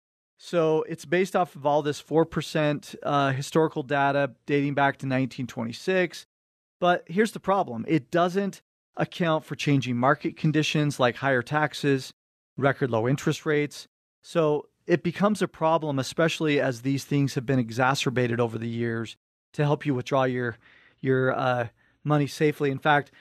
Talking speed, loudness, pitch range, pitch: 155 wpm, -26 LUFS, 130-160 Hz, 145 Hz